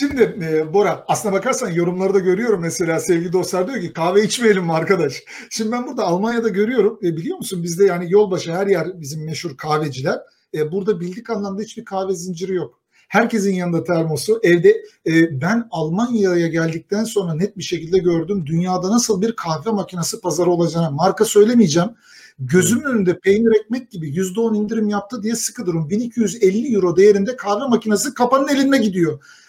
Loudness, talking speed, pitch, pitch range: -18 LUFS, 165 wpm, 195 Hz, 175-220 Hz